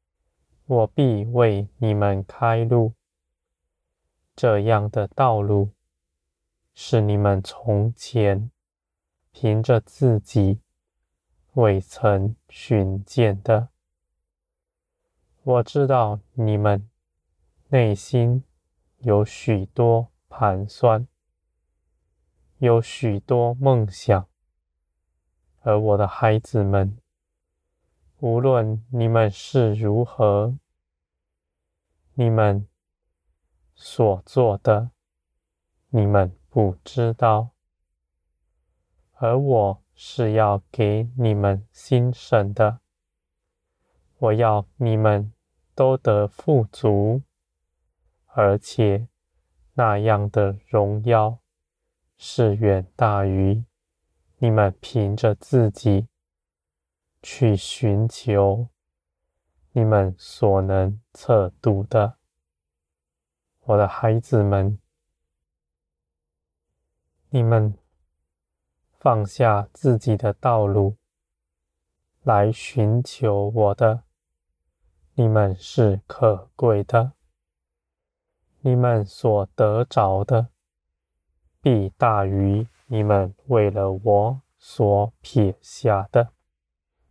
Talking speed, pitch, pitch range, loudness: 105 characters per minute, 100 Hz, 75-115 Hz, -21 LUFS